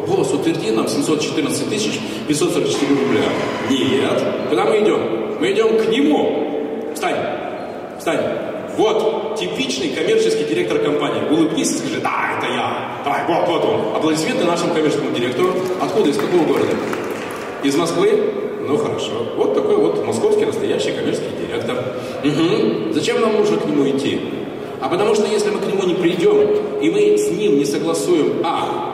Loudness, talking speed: -18 LUFS, 155 wpm